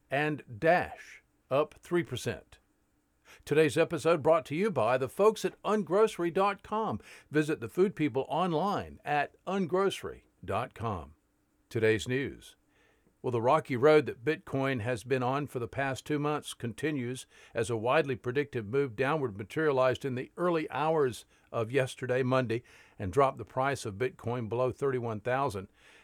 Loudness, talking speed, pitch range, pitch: -31 LUFS, 140 wpm, 125-160 Hz, 135 Hz